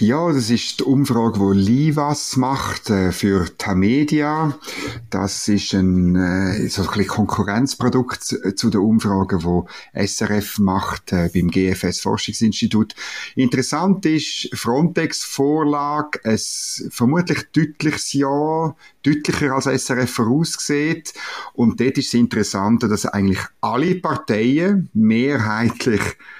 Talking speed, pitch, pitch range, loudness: 115 wpm, 120 Hz, 100-145 Hz, -19 LUFS